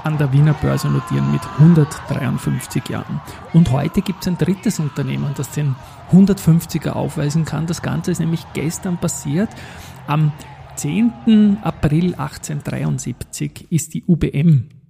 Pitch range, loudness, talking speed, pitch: 145-170 Hz, -18 LUFS, 135 wpm, 155 Hz